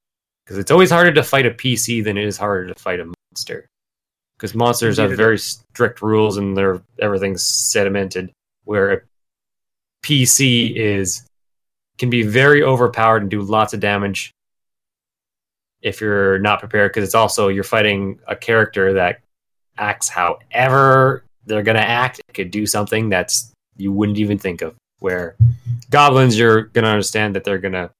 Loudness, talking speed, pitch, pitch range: -16 LUFS, 160 wpm, 110 Hz, 100-120 Hz